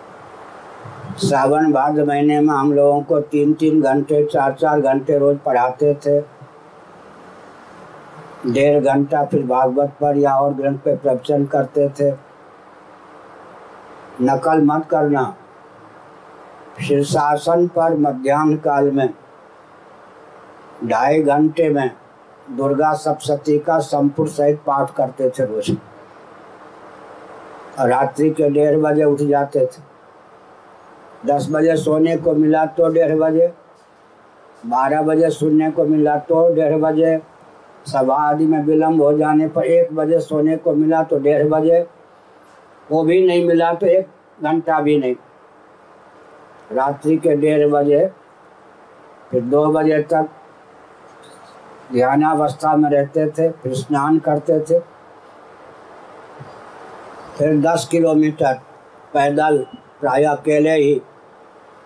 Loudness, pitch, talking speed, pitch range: -16 LUFS, 150 Hz, 115 wpm, 140-155 Hz